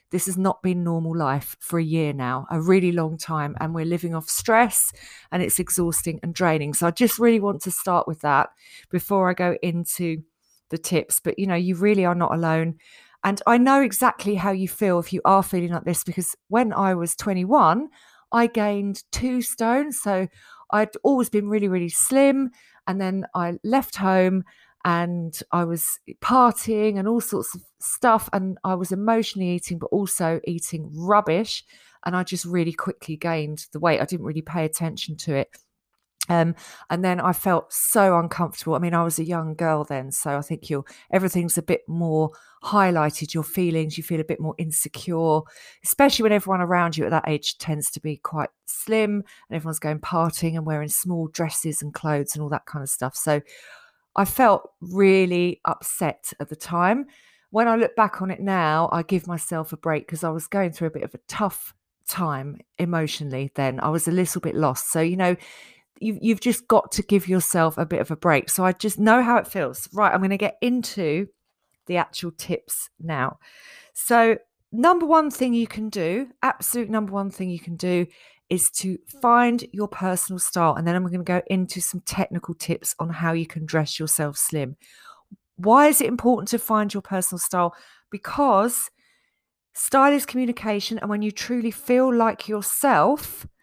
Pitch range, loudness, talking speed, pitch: 165-210 Hz, -22 LUFS, 195 wpm, 180 Hz